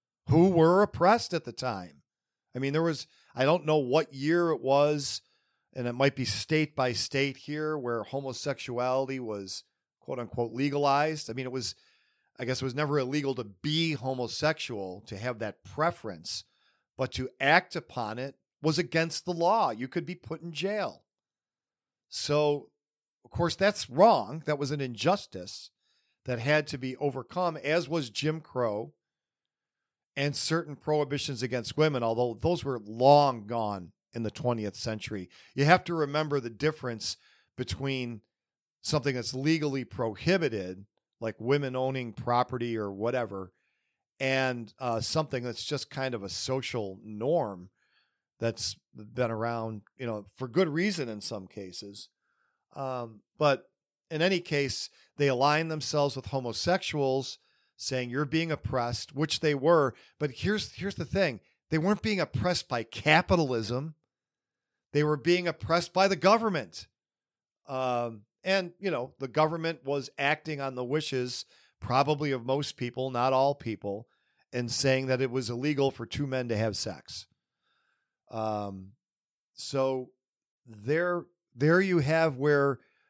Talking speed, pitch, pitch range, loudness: 150 wpm, 135 Hz, 120-155 Hz, -29 LUFS